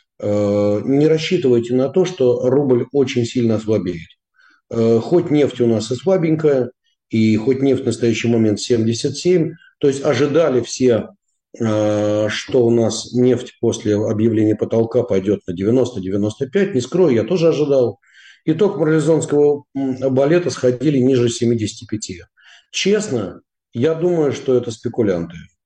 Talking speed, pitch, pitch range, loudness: 125 wpm, 125 Hz, 110-145 Hz, -17 LUFS